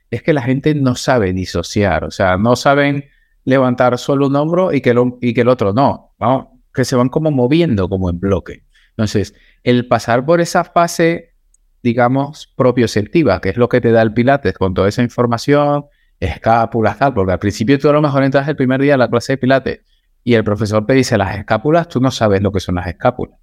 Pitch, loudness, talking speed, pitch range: 125 Hz, -14 LUFS, 220 wpm, 110-140 Hz